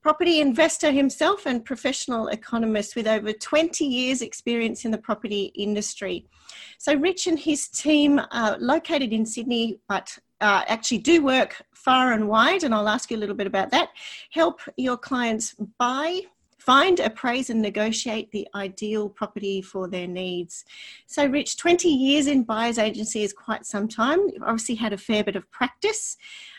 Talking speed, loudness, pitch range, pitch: 165 wpm, -23 LUFS, 215-290 Hz, 235 Hz